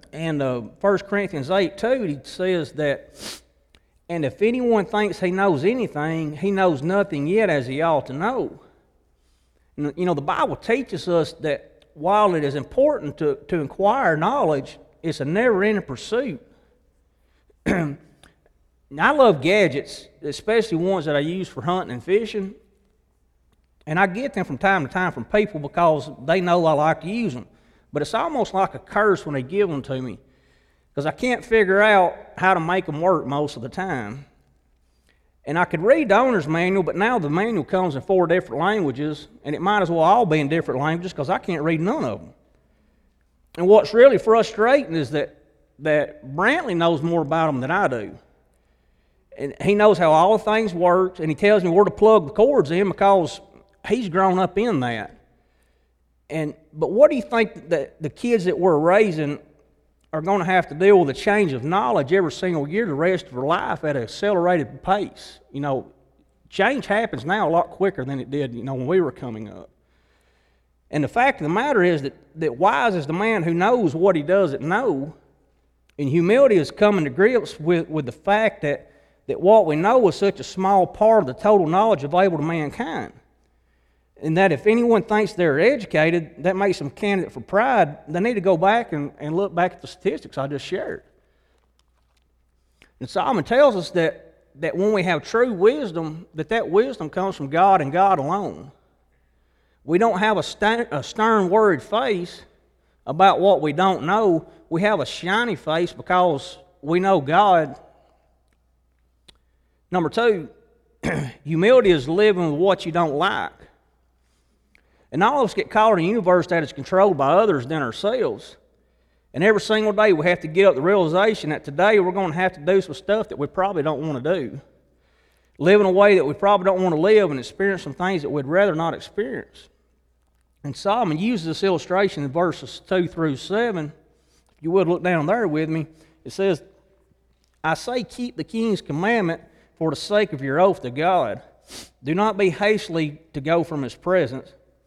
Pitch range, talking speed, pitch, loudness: 140-195 Hz, 190 wpm, 170 Hz, -20 LUFS